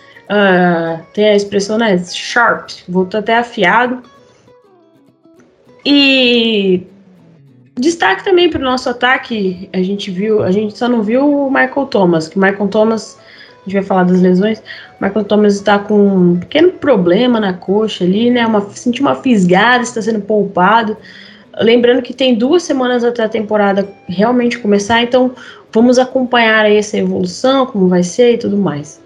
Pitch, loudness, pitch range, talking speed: 215 Hz, -12 LUFS, 195-245 Hz, 155 wpm